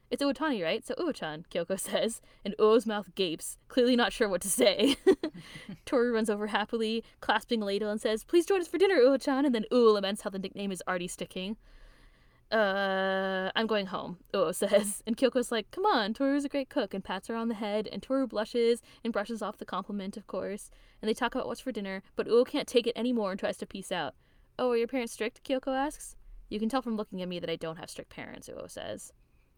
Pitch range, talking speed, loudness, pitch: 195-245 Hz, 230 wpm, -30 LUFS, 220 Hz